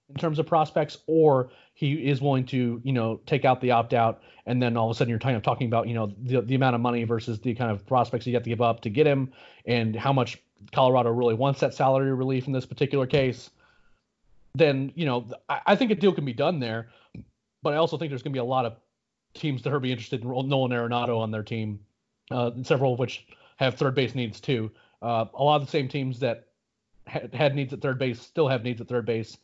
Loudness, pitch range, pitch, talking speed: -26 LUFS, 120-140 Hz, 130 Hz, 250 wpm